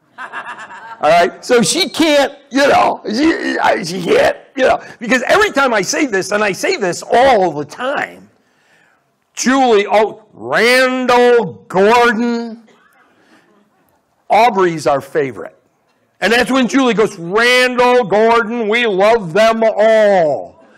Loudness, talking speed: -13 LUFS, 125 wpm